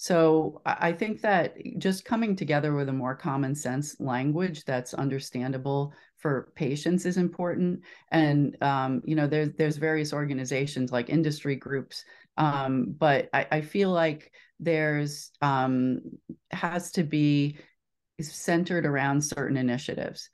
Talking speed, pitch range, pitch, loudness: 135 wpm, 135-170 Hz, 150 Hz, -28 LUFS